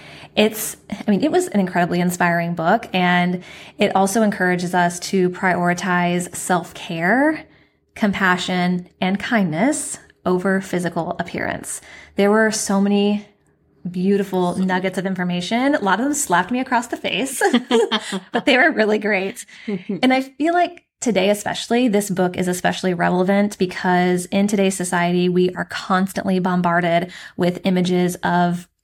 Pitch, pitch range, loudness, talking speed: 190 Hz, 180-215 Hz, -19 LUFS, 140 wpm